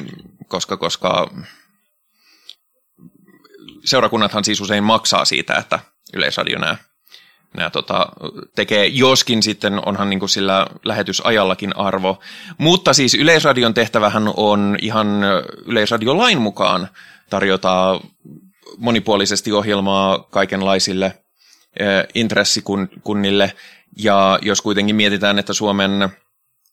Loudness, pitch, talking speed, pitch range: -16 LUFS, 100 Hz, 90 wpm, 100-110 Hz